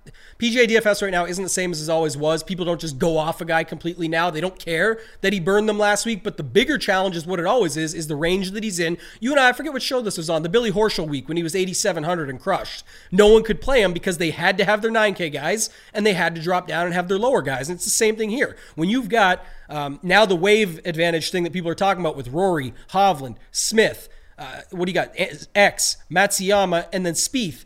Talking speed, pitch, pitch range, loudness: 265 wpm, 185 Hz, 165-210 Hz, -20 LUFS